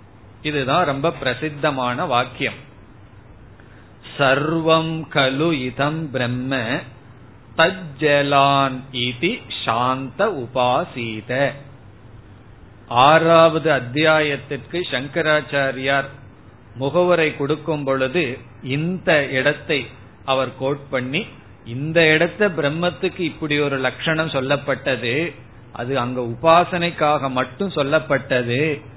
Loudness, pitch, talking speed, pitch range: -19 LUFS, 135 Hz, 60 wpm, 125-155 Hz